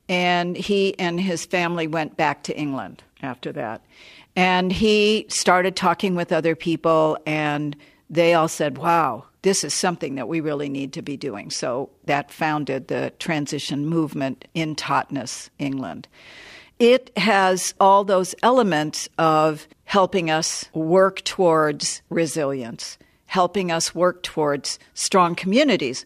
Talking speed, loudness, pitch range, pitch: 135 wpm, -21 LUFS, 150-185 Hz, 165 Hz